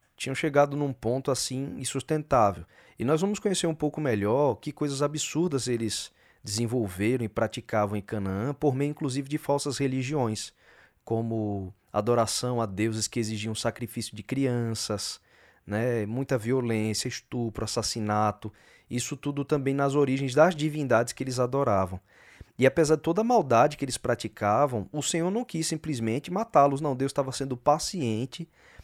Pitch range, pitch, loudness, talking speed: 110-145 Hz, 130 Hz, -28 LUFS, 150 wpm